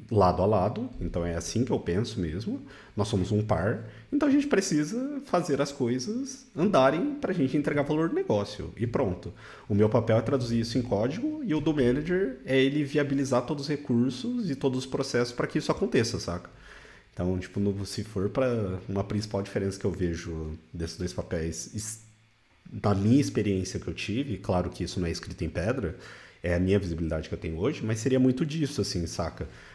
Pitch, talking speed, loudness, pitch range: 110 Hz, 200 wpm, -28 LUFS, 95-135 Hz